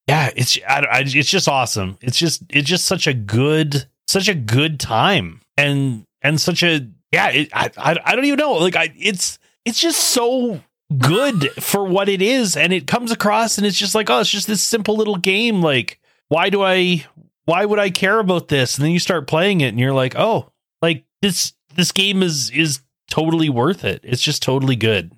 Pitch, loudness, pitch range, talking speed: 165 Hz, -17 LUFS, 140-200 Hz, 210 wpm